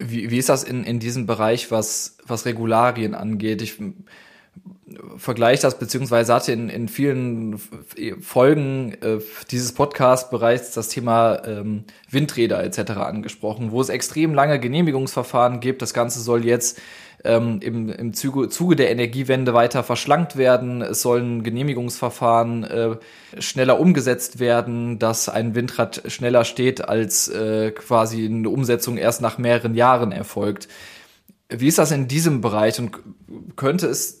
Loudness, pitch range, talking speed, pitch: -20 LUFS, 115-130 Hz, 150 wpm, 120 Hz